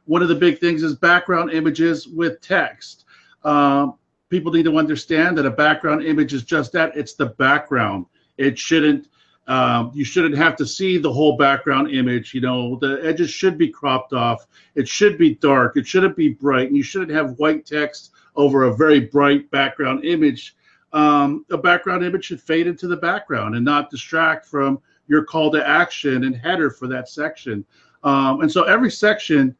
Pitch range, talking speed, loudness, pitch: 135-165 Hz, 185 wpm, -18 LUFS, 150 Hz